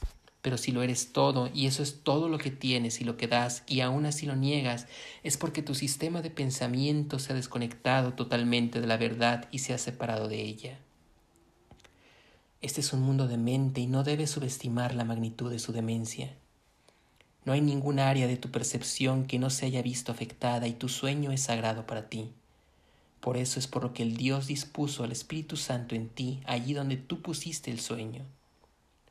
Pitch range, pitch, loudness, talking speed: 120-140 Hz, 125 Hz, -31 LUFS, 195 wpm